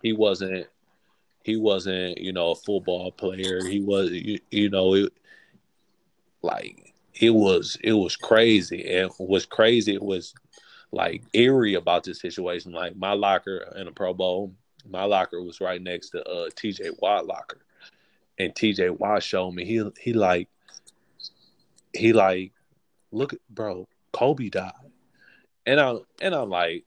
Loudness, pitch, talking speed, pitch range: -24 LUFS, 95 Hz, 150 wpm, 90-110 Hz